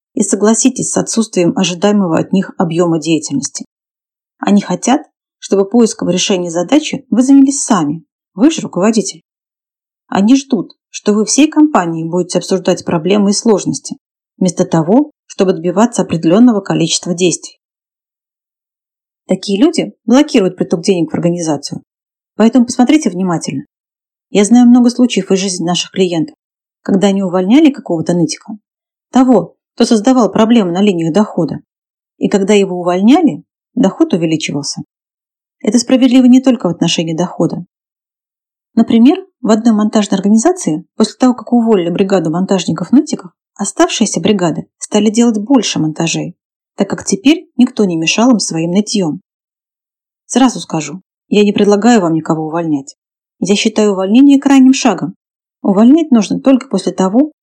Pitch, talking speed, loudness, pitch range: 205 Hz, 130 wpm, -12 LUFS, 180-245 Hz